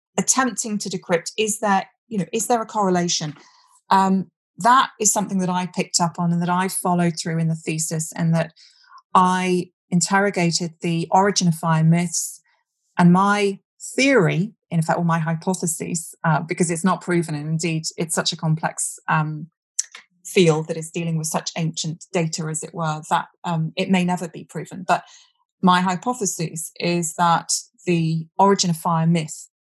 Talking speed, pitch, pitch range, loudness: 175 wpm, 175 Hz, 165-190 Hz, -21 LUFS